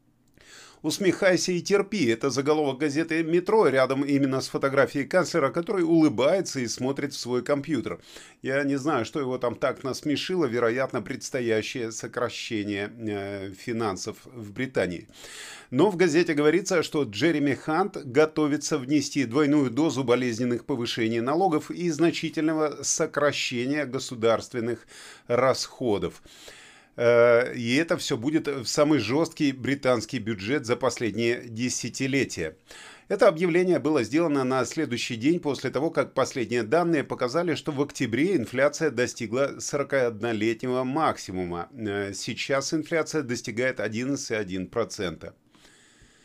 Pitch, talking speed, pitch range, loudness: 140 Hz, 115 wpm, 120-155 Hz, -26 LUFS